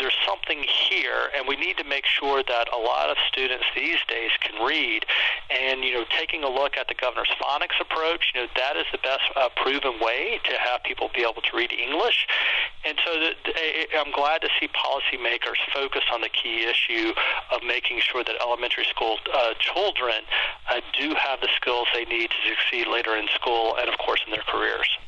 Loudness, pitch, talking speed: -23 LUFS, 135 Hz, 205 wpm